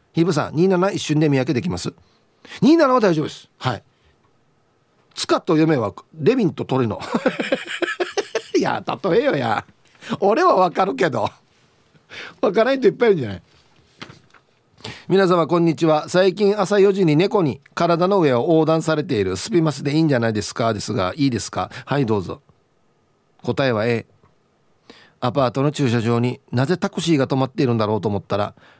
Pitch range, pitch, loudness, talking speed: 120-185 Hz, 155 Hz, -19 LUFS, 320 characters per minute